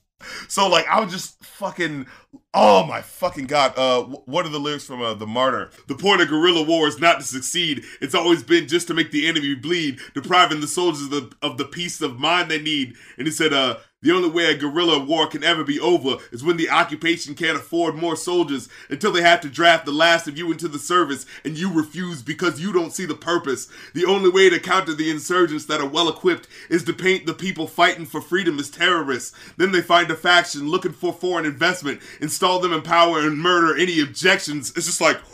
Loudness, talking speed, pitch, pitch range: -20 LUFS, 225 wpm, 165 Hz, 150-175 Hz